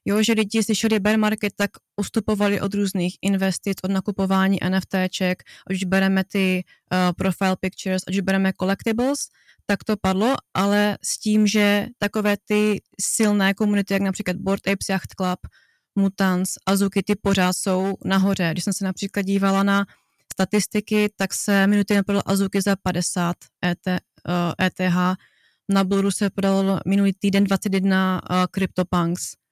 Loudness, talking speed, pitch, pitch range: -22 LUFS, 145 wpm, 195 Hz, 190-205 Hz